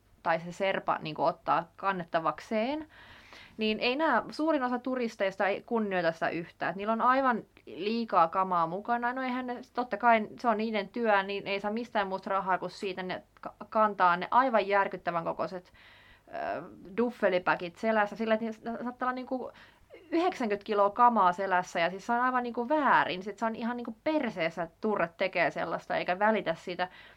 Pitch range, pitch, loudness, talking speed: 185-240 Hz, 210 Hz, -30 LUFS, 175 wpm